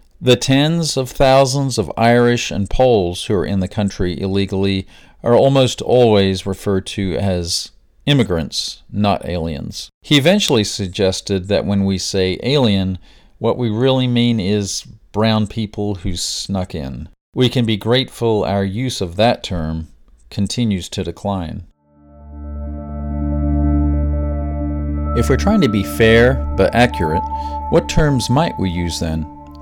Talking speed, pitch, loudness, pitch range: 135 wpm, 100 Hz, -17 LUFS, 80-115 Hz